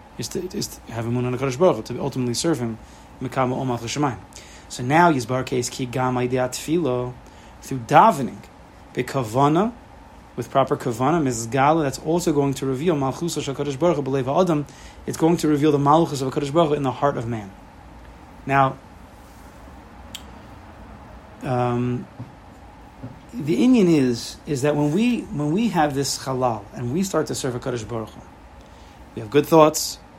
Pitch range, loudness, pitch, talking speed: 120-150 Hz, -21 LUFS, 130 Hz, 160 wpm